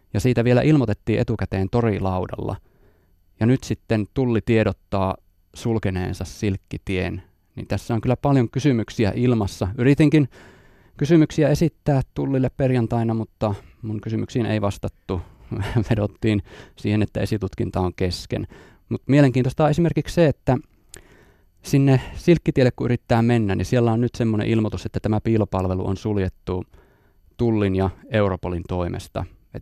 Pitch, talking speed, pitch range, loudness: 110 Hz, 125 wpm, 95-125 Hz, -22 LUFS